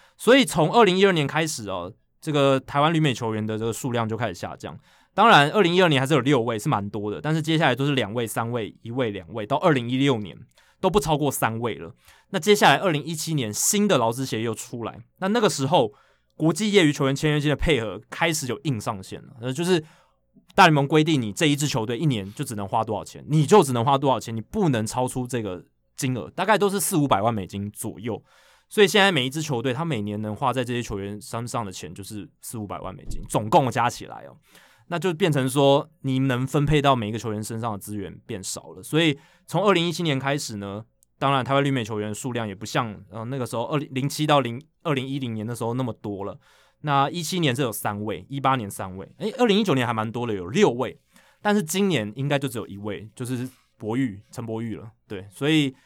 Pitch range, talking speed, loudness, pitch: 110-155 Hz, 350 characters per minute, -23 LUFS, 135 Hz